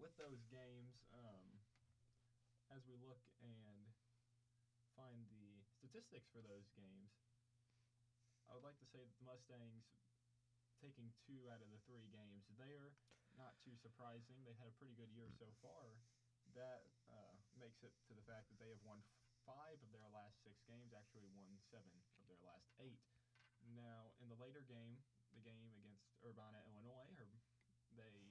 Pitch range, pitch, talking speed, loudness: 110-125 Hz, 120 Hz, 165 wpm, -65 LUFS